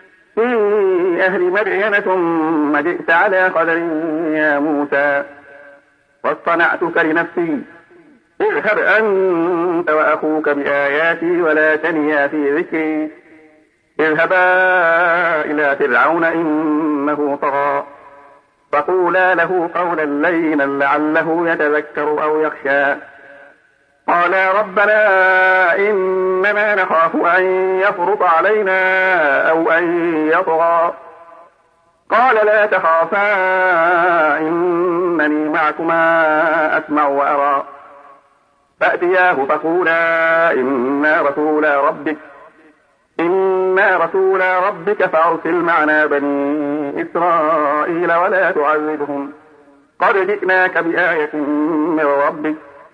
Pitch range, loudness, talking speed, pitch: 150-185 Hz, -15 LUFS, 75 wpm, 165 Hz